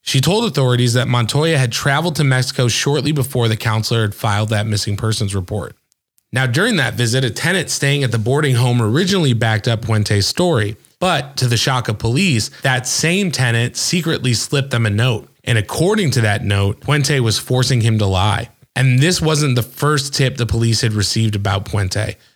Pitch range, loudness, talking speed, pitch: 110-140 Hz, -16 LUFS, 195 wpm, 125 Hz